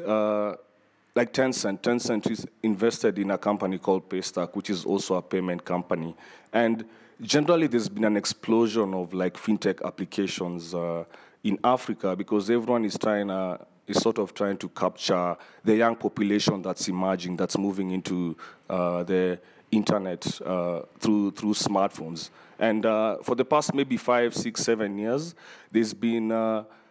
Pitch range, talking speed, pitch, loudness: 95-115 Hz, 165 wpm, 105 Hz, -27 LUFS